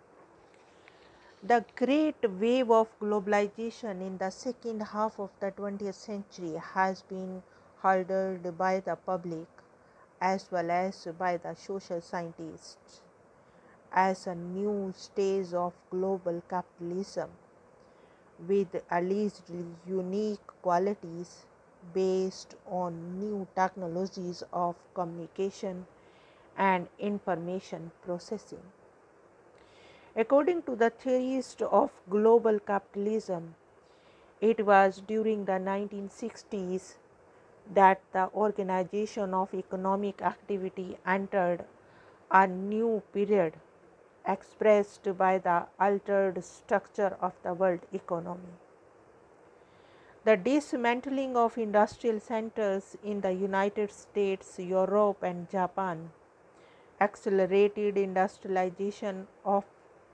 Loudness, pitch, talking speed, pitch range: -30 LUFS, 195 Hz, 95 wpm, 185-215 Hz